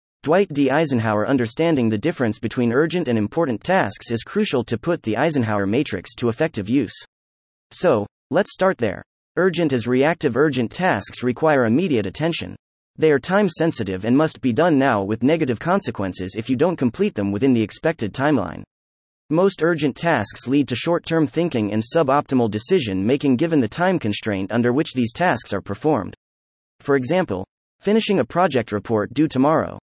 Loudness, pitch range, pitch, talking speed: -20 LUFS, 110-160 Hz, 130 Hz, 160 wpm